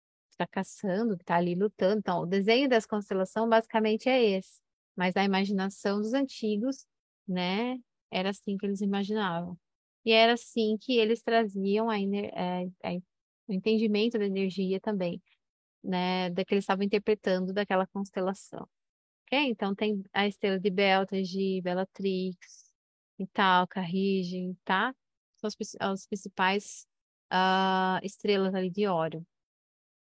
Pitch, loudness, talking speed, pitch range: 195 Hz, -29 LUFS, 130 wpm, 185-215 Hz